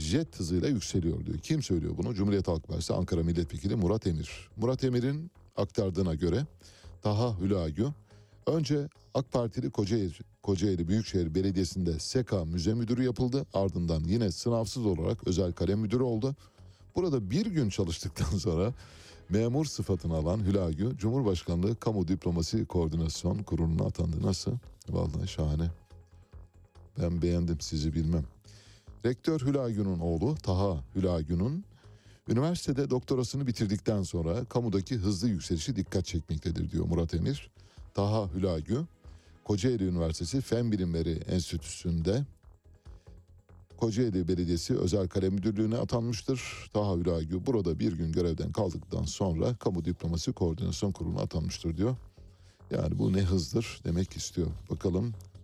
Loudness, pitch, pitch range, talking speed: -31 LUFS, 95 Hz, 85-115 Hz, 120 wpm